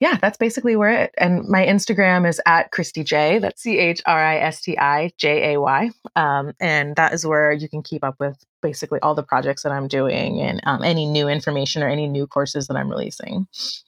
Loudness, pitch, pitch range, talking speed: -19 LUFS, 155 Hz, 145-185 Hz, 185 wpm